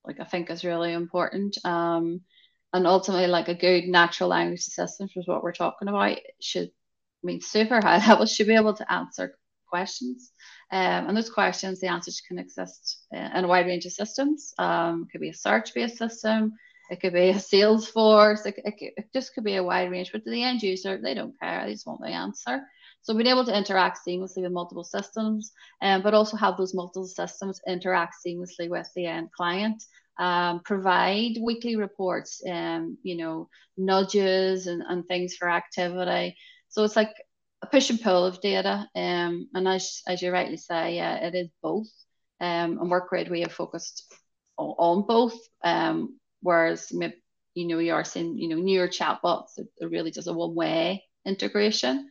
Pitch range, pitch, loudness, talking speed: 175-210 Hz, 185 Hz, -26 LUFS, 185 wpm